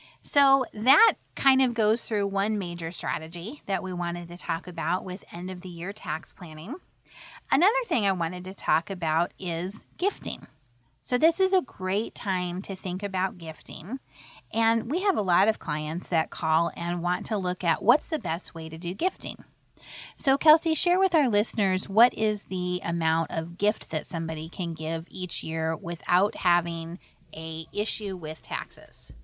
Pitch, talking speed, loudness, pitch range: 180 Hz, 175 wpm, -27 LUFS, 165-215 Hz